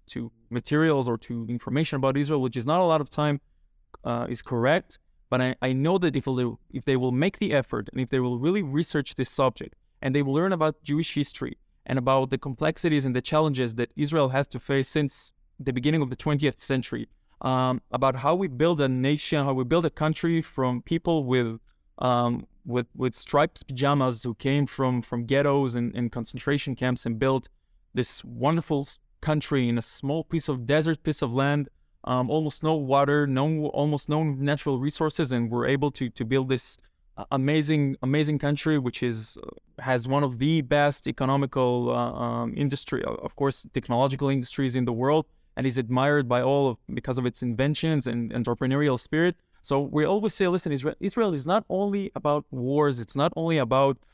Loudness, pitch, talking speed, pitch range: -26 LUFS, 140 Hz, 190 wpm, 125-150 Hz